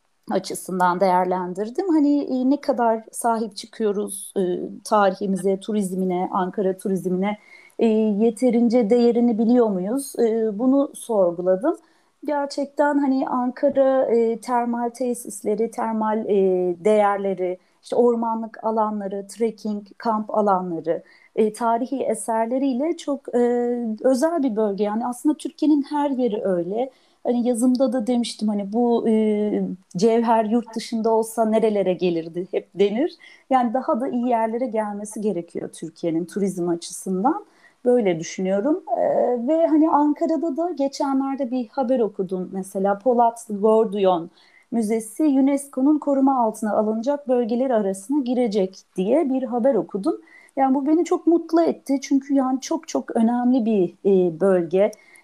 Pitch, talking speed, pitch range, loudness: 230 Hz, 125 wpm, 200-270 Hz, -22 LUFS